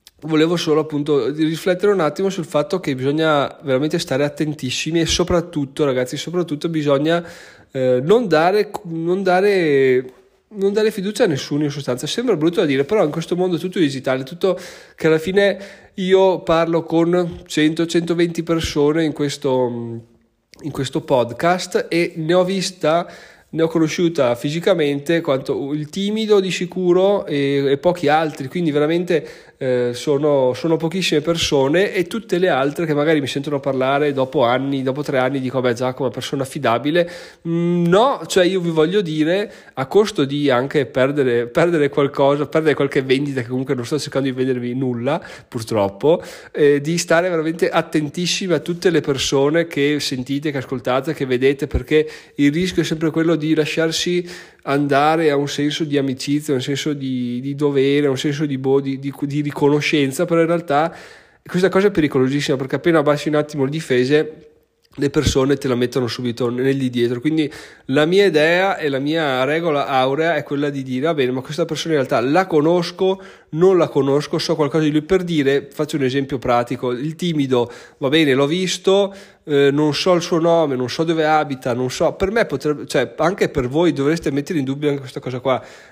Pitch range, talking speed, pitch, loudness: 135-170 Hz, 180 wpm, 150 Hz, -18 LUFS